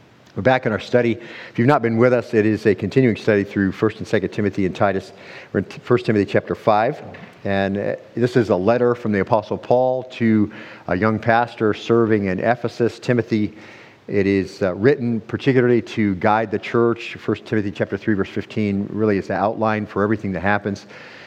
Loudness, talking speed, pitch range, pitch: -20 LUFS, 190 wpm, 100-115 Hz, 110 Hz